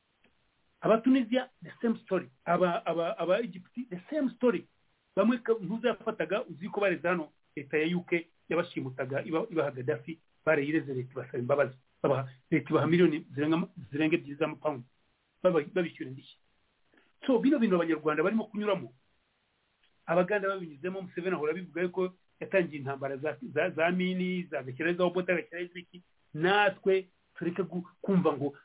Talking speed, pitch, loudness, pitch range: 125 wpm, 170 Hz, -31 LUFS, 150-190 Hz